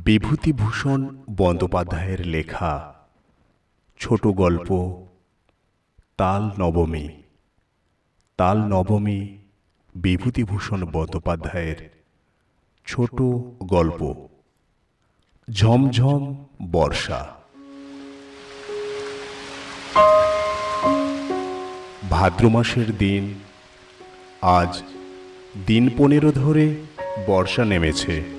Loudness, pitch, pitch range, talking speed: -21 LUFS, 100 Hz, 90-125 Hz, 50 wpm